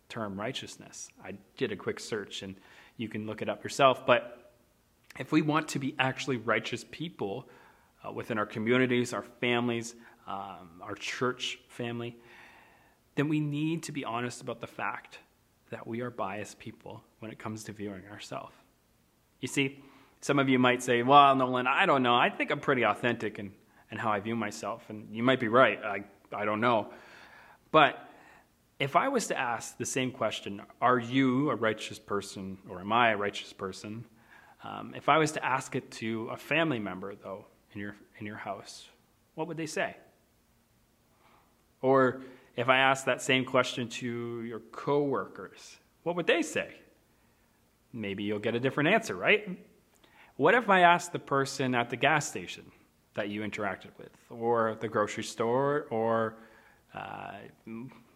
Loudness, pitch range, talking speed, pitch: -29 LUFS, 110-135 Hz, 170 wpm, 120 Hz